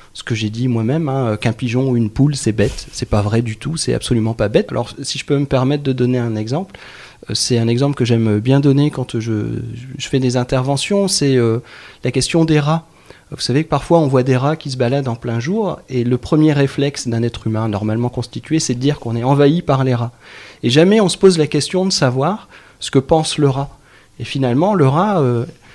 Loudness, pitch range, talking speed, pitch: -16 LUFS, 120-145 Hz, 240 wpm, 130 Hz